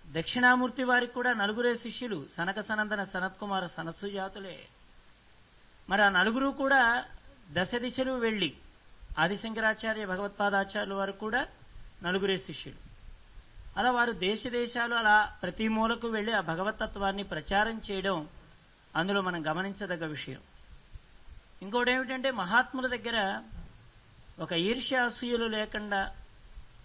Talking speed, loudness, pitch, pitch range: 100 wpm, -30 LUFS, 205 Hz, 180-235 Hz